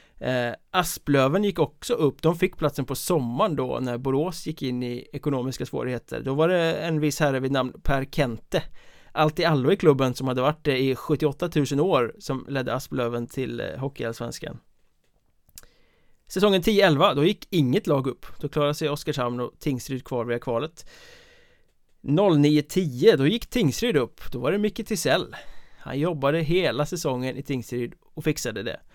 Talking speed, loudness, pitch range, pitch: 170 wpm, -25 LUFS, 130-165 Hz, 145 Hz